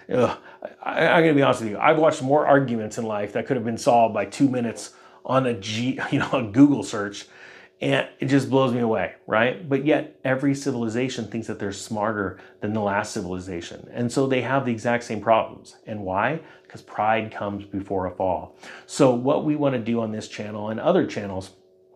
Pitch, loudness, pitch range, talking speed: 115 Hz, -23 LUFS, 105-135 Hz, 210 wpm